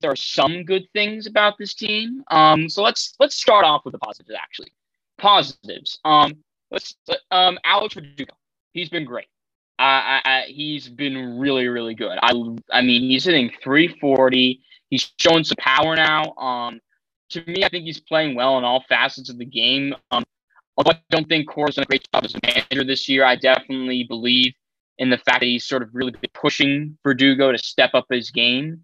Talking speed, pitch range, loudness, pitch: 195 wpm, 125-165 Hz, -18 LUFS, 135 Hz